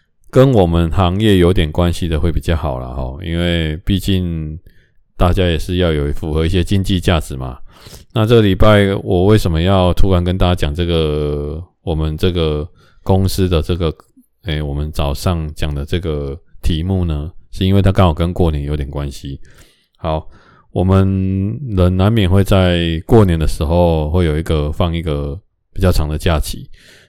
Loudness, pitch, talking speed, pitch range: -16 LUFS, 85 Hz, 255 characters per minute, 75-95 Hz